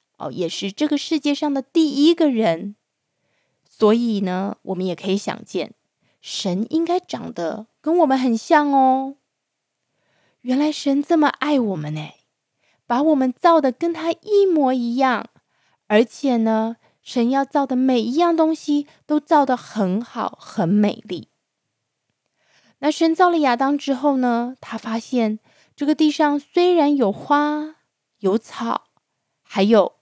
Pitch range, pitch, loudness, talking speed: 220-300 Hz, 265 Hz, -20 LUFS, 195 characters per minute